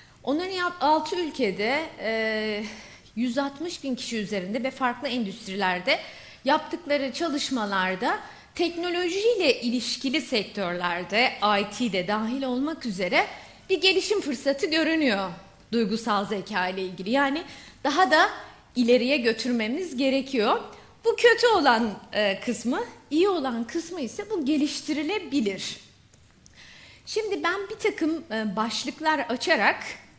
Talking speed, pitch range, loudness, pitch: 100 wpm, 220-330 Hz, -25 LUFS, 270 Hz